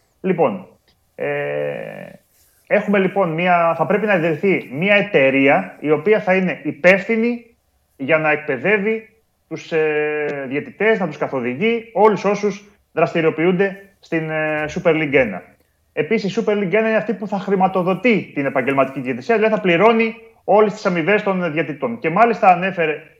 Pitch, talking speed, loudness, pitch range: 185 Hz, 145 wpm, -18 LUFS, 155-210 Hz